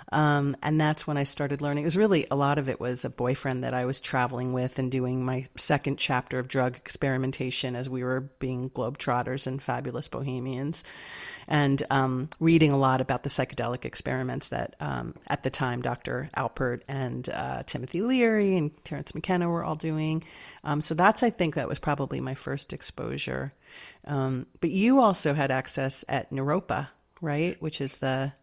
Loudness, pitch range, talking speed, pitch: -28 LUFS, 130-155 Hz, 185 wpm, 135 Hz